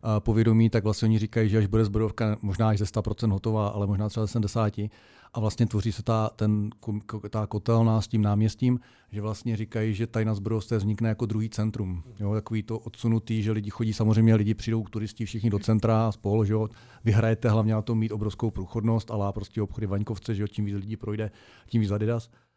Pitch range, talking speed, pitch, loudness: 105-115 Hz, 200 wpm, 110 Hz, -27 LUFS